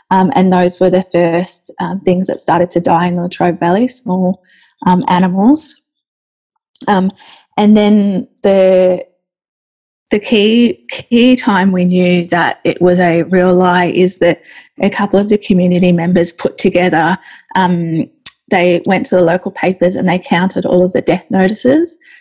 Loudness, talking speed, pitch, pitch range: -12 LUFS, 160 wpm, 185 Hz, 180-205 Hz